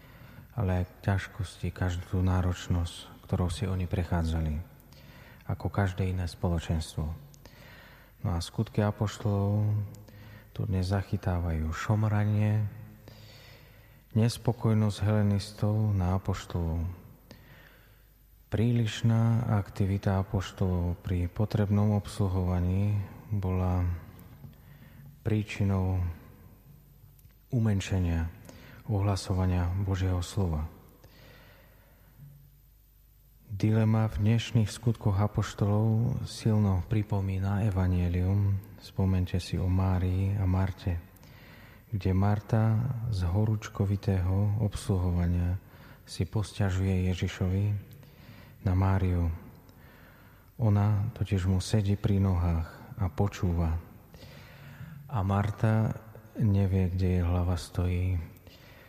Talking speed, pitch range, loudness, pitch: 75 wpm, 90-110 Hz, -30 LUFS, 100 Hz